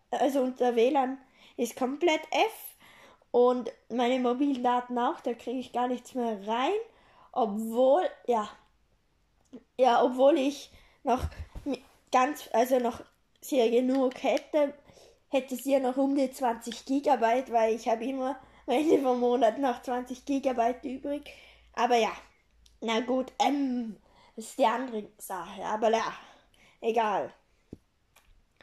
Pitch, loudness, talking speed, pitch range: 250 Hz, -28 LUFS, 130 wpm, 235-270 Hz